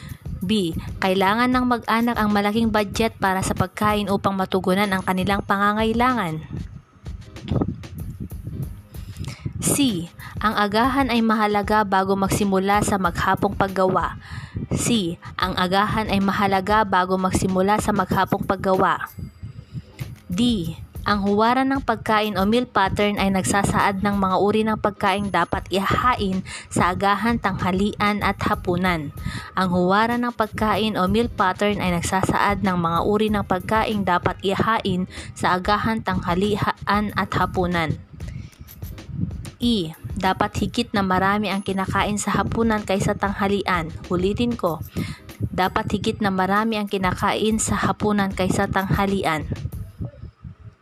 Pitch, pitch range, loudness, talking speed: 200 Hz, 185-210 Hz, -21 LUFS, 120 wpm